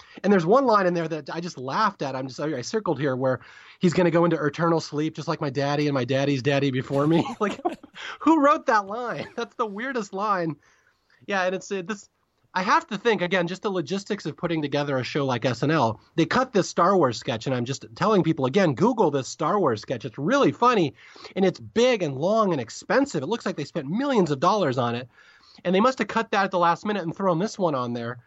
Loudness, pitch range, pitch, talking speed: -24 LUFS, 145-210 Hz, 175 Hz, 245 wpm